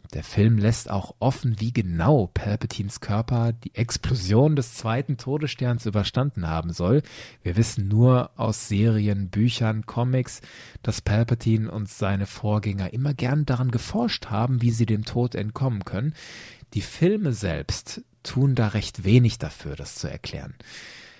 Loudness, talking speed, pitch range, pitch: -24 LUFS, 145 wpm, 105-125 Hz, 115 Hz